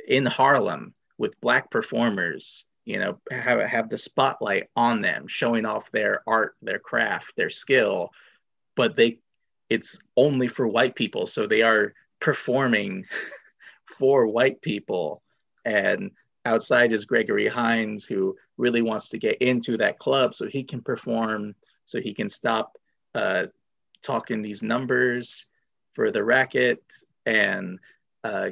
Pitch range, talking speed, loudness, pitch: 110-125 Hz, 135 wpm, -24 LUFS, 120 Hz